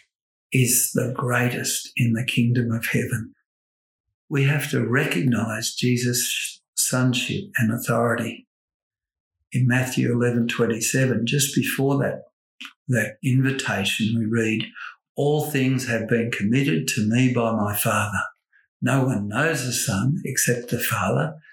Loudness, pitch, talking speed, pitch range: -22 LUFS, 120 Hz, 125 wpm, 115-130 Hz